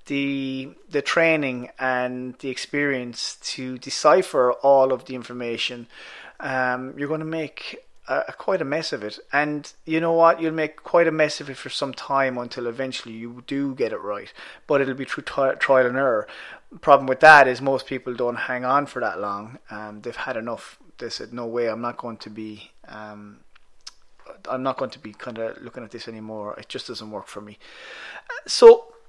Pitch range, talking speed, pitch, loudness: 120-145 Hz, 200 wpm, 130 Hz, -22 LUFS